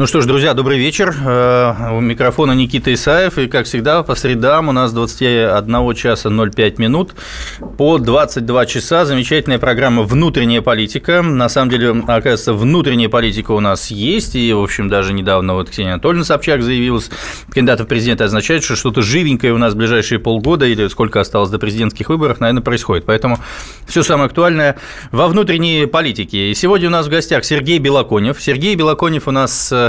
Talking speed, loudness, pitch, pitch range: 175 wpm, -13 LUFS, 125 Hz, 115-145 Hz